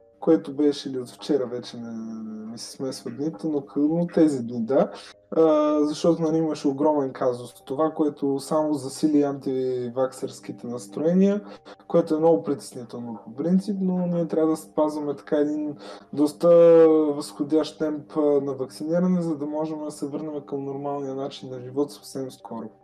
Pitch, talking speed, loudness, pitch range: 145 Hz, 150 wpm, -24 LUFS, 130-155 Hz